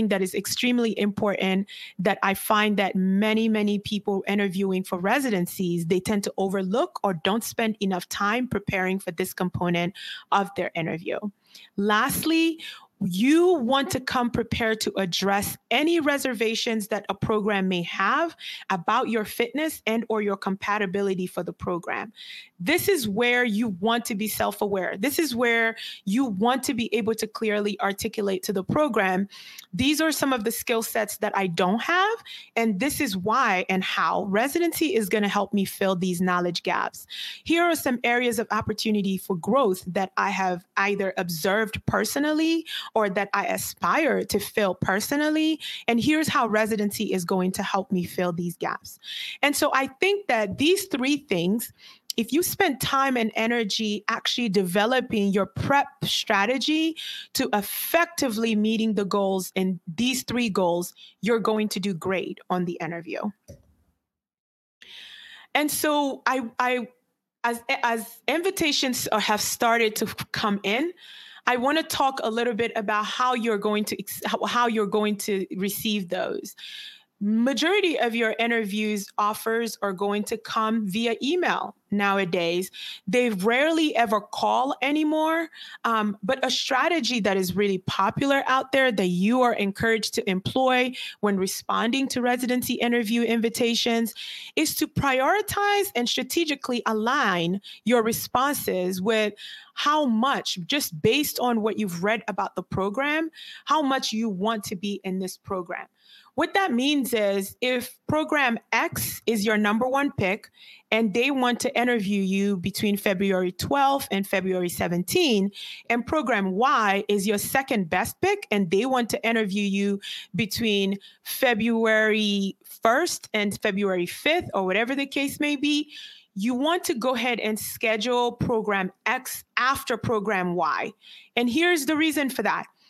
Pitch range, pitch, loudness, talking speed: 200-260 Hz, 225 Hz, -24 LUFS, 155 wpm